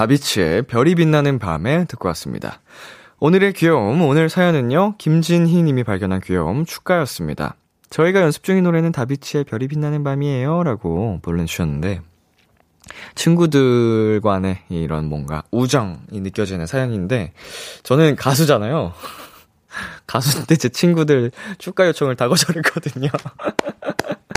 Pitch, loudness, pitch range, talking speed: 140 Hz, -18 LUFS, 100-165 Hz, 305 characters per minute